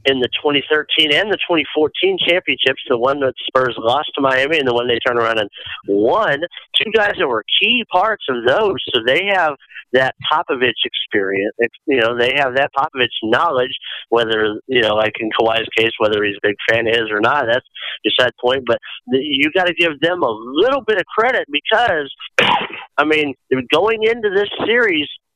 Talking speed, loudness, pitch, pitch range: 195 wpm, -16 LUFS, 135 Hz, 115-175 Hz